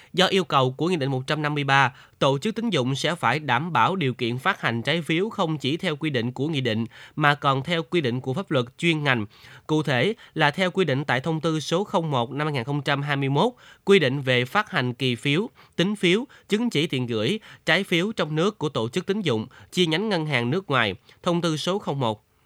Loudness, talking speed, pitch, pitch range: -24 LUFS, 225 wpm, 150 Hz, 130-180 Hz